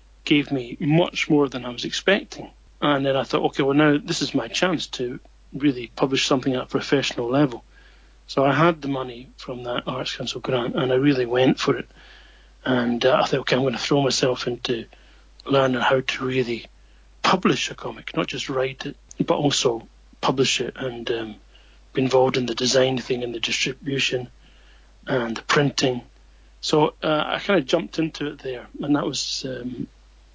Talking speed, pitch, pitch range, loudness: 190 wpm, 130 Hz, 120-145 Hz, -22 LUFS